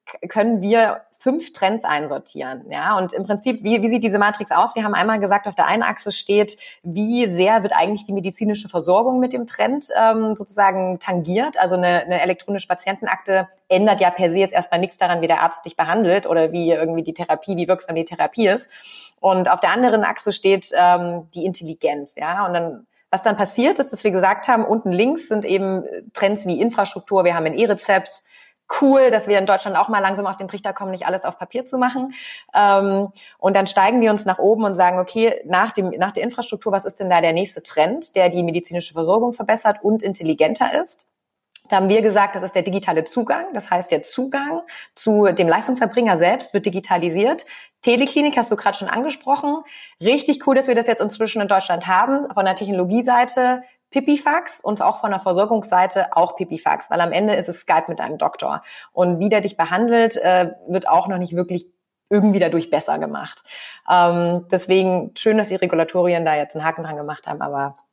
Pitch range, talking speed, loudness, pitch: 180-225 Hz, 200 wpm, -19 LUFS, 200 Hz